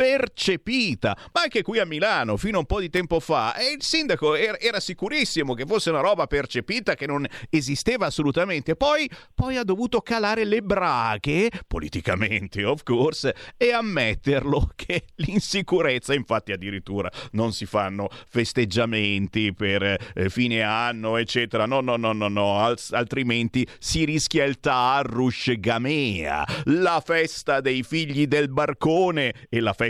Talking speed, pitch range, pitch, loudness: 150 wpm, 115-180 Hz, 140 Hz, -23 LUFS